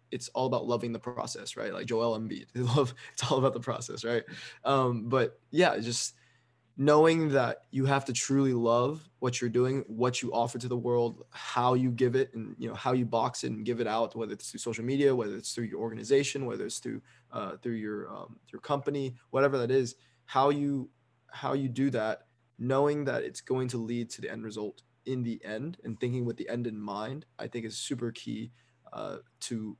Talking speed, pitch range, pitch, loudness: 215 wpm, 115-135 Hz, 125 Hz, -31 LUFS